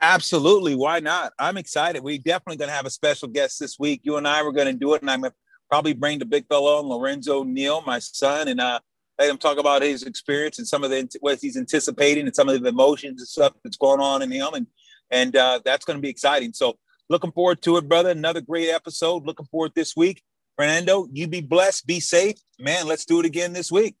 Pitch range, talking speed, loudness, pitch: 140-170 Hz, 245 wpm, -22 LUFS, 150 Hz